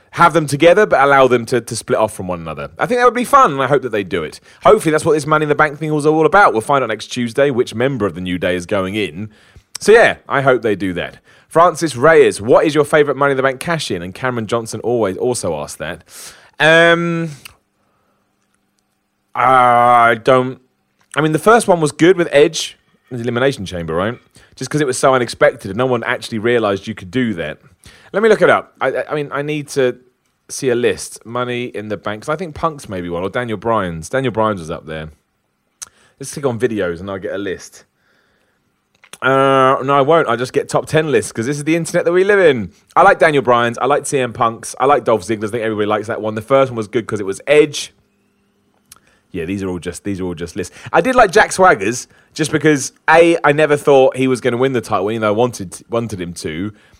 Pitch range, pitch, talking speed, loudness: 105-150 Hz, 125 Hz, 240 wpm, -15 LUFS